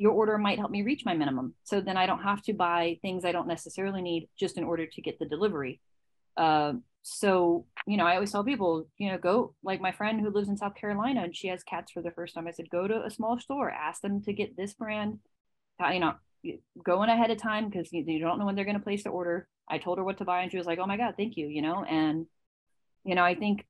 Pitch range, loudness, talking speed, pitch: 170-210 Hz, -30 LUFS, 270 wpm, 190 Hz